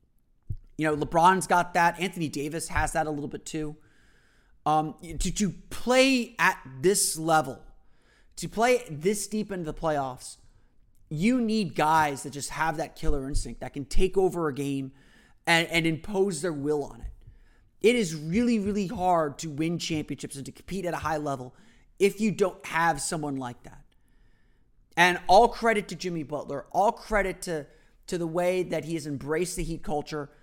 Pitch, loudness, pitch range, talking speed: 160 Hz, -27 LUFS, 145-185 Hz, 180 wpm